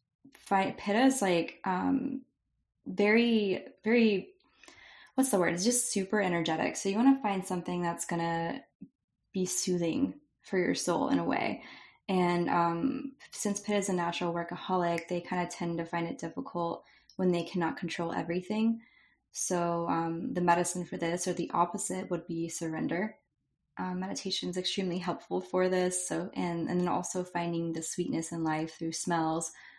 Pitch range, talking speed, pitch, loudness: 170-200 Hz, 165 wpm, 180 Hz, -31 LUFS